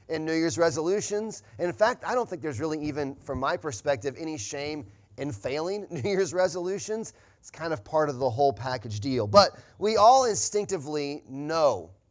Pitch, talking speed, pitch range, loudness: 155 Hz, 185 wpm, 140-190 Hz, -27 LUFS